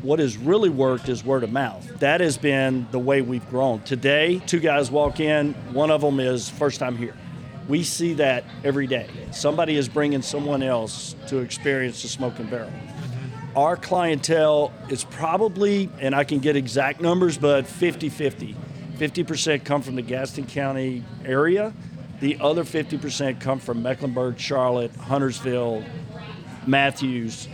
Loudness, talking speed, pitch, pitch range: -23 LUFS, 155 wpm, 140 Hz, 130-150 Hz